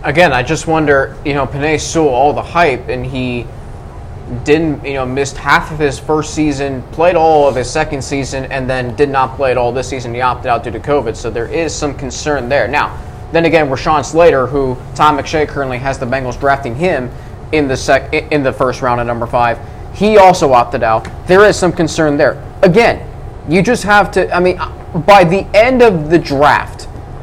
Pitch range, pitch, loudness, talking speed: 125-155 Hz, 140 Hz, -12 LUFS, 210 wpm